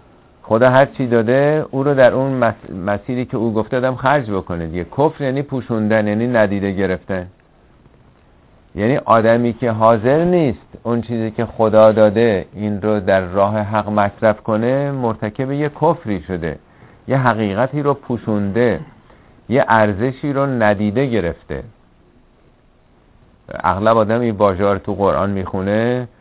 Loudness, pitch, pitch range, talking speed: -17 LUFS, 115 Hz, 105-130 Hz, 135 wpm